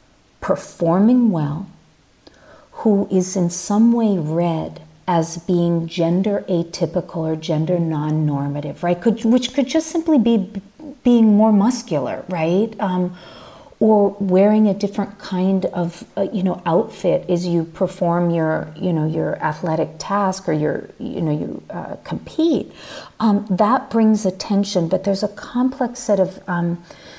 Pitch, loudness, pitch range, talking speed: 185 Hz, -19 LUFS, 170-215 Hz, 140 wpm